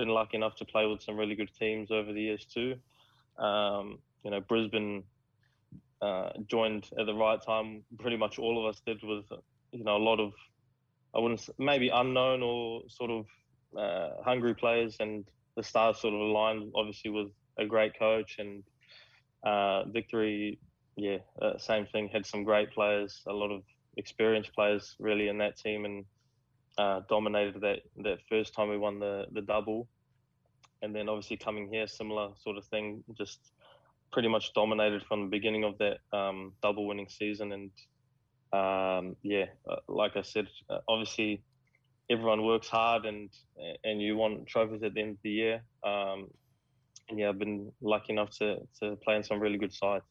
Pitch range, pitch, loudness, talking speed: 105-115 Hz, 110 Hz, -32 LUFS, 175 wpm